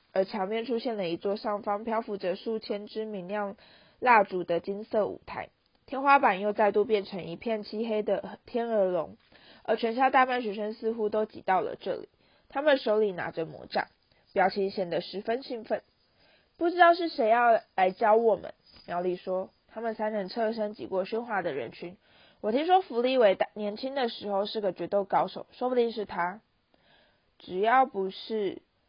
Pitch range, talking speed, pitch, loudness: 195-235 Hz, 260 characters per minute, 215 Hz, -28 LUFS